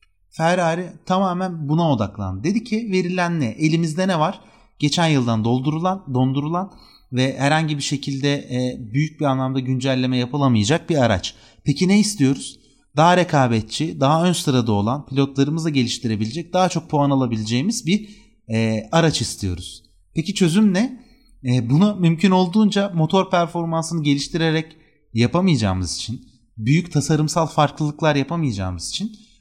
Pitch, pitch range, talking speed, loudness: 150 Hz, 125-175 Hz, 130 wpm, -20 LUFS